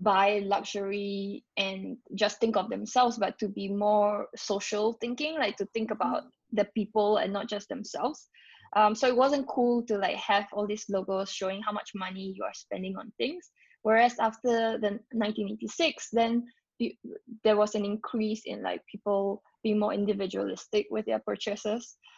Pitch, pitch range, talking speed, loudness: 210 Hz, 200-225 Hz, 165 wpm, -30 LUFS